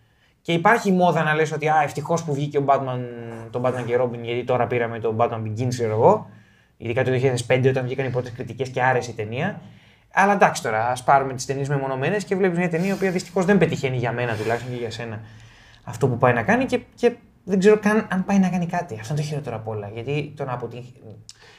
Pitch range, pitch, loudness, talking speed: 120-165 Hz, 130 Hz, -22 LUFS, 230 wpm